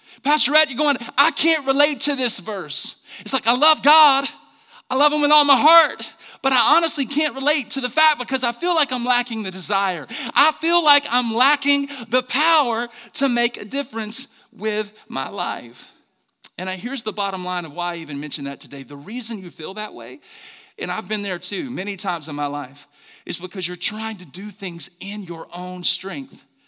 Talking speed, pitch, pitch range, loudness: 205 wpm, 235 Hz, 190-285 Hz, -19 LUFS